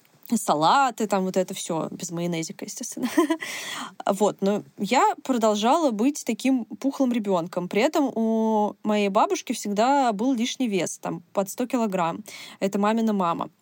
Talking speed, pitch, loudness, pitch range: 140 wpm, 225 Hz, -24 LUFS, 200-260 Hz